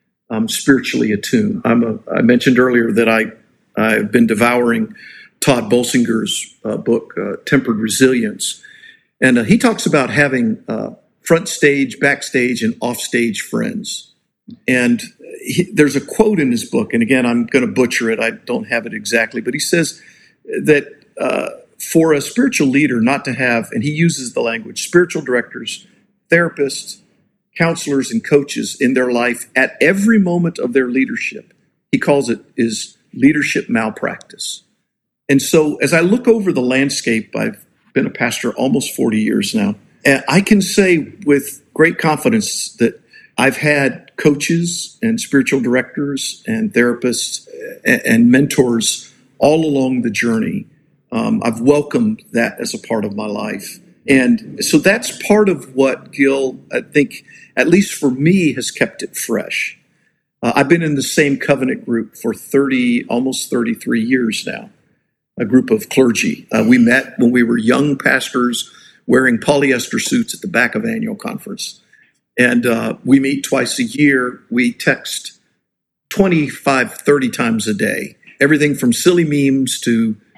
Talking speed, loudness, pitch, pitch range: 160 wpm, -15 LUFS, 145 Hz, 125-210 Hz